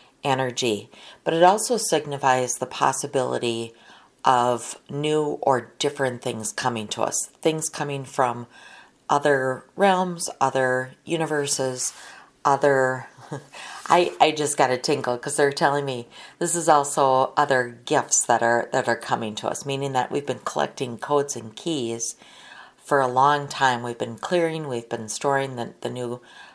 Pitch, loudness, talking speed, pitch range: 130 Hz, -23 LUFS, 150 wpm, 120-145 Hz